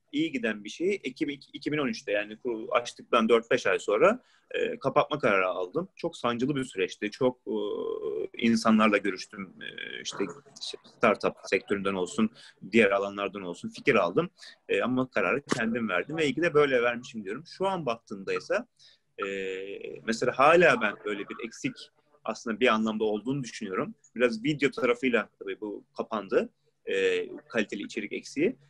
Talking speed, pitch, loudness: 150 wpm, 130 Hz, -28 LUFS